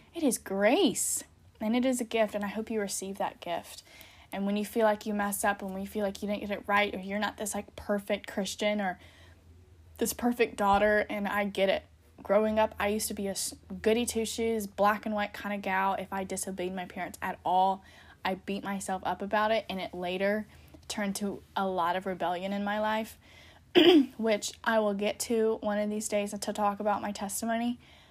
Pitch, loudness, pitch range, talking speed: 205 Hz, -30 LUFS, 195-215 Hz, 220 wpm